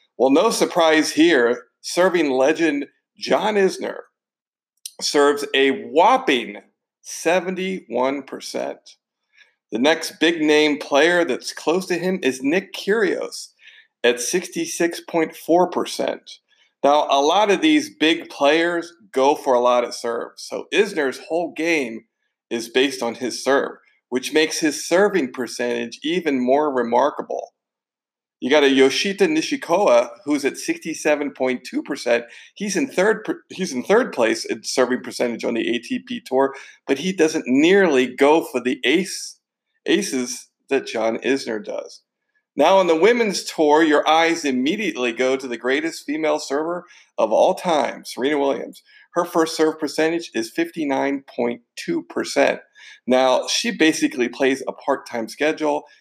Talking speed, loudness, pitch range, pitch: 130 wpm, -20 LUFS, 130-195 Hz, 155 Hz